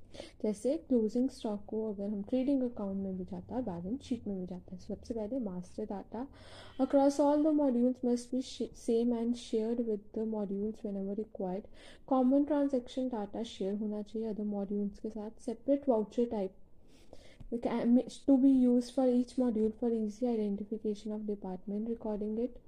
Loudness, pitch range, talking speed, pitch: -34 LUFS, 210-250 Hz, 165 wpm, 225 Hz